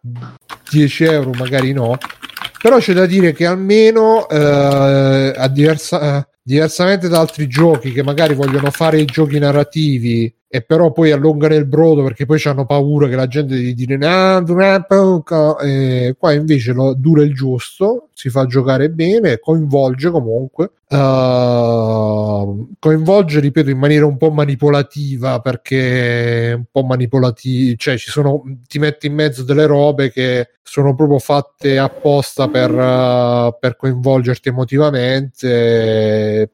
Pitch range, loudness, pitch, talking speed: 130-155 Hz, -13 LUFS, 140 Hz, 140 wpm